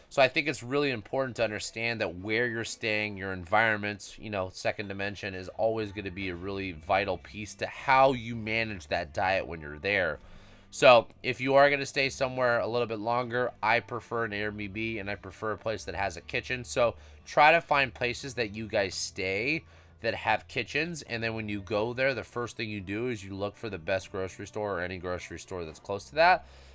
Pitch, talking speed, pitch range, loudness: 110 Hz, 225 wpm, 100-120 Hz, -29 LUFS